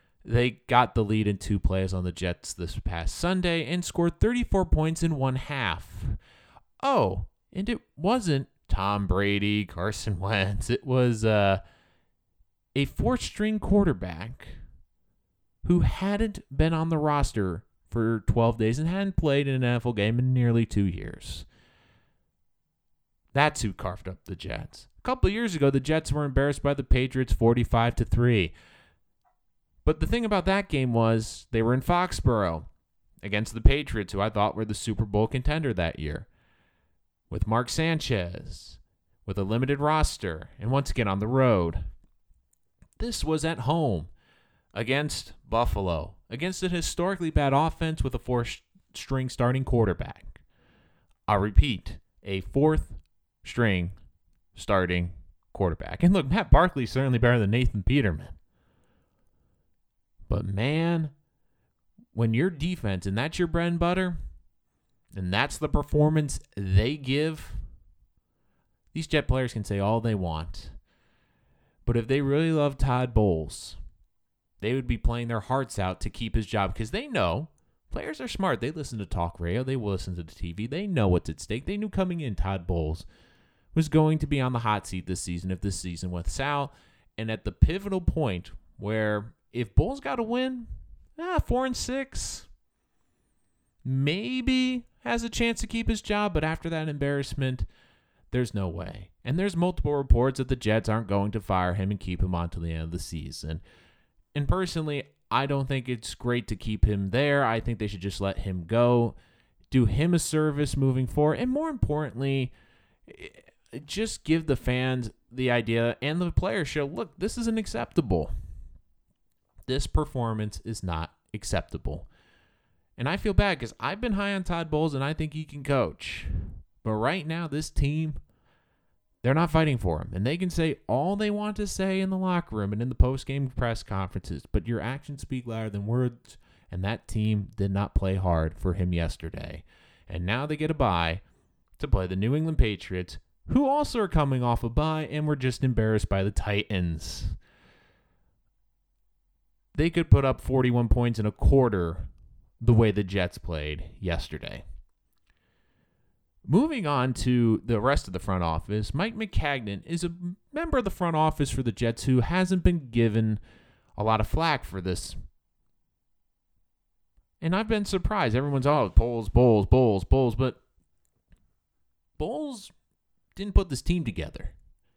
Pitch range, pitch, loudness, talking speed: 95-150 Hz, 115 Hz, -27 LUFS, 165 wpm